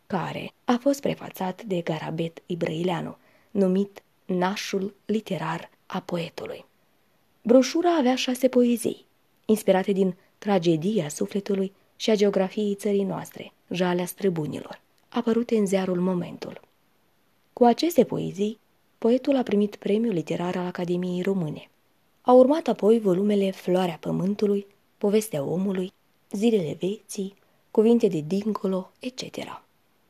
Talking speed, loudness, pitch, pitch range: 110 wpm, -25 LUFS, 200 Hz, 185-220 Hz